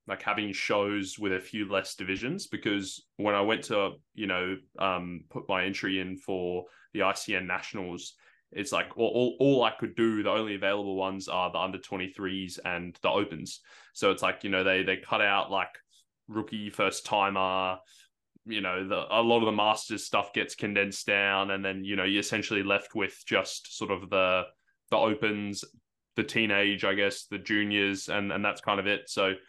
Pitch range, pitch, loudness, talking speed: 95-105 Hz, 100 Hz, -29 LUFS, 195 wpm